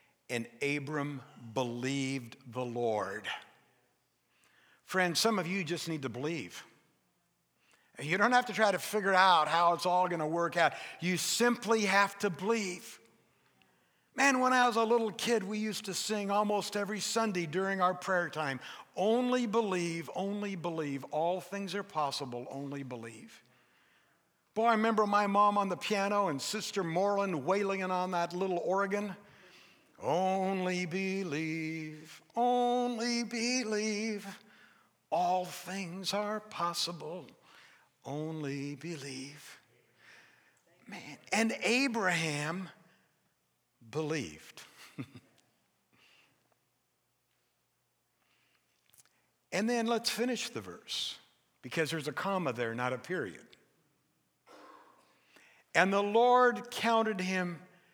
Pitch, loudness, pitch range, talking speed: 185 Hz, -32 LUFS, 155-215 Hz, 115 wpm